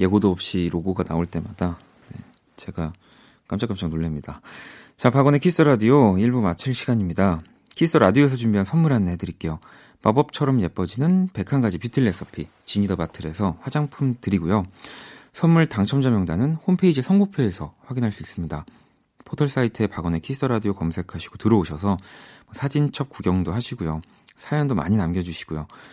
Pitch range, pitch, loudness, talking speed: 90-135 Hz, 105 Hz, -22 LUFS, 370 characters per minute